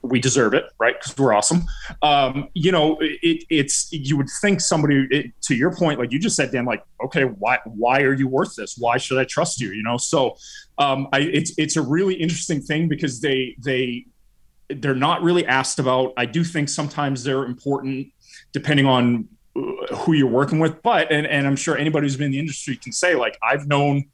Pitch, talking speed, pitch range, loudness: 140 Hz, 210 wpm, 135-160 Hz, -20 LUFS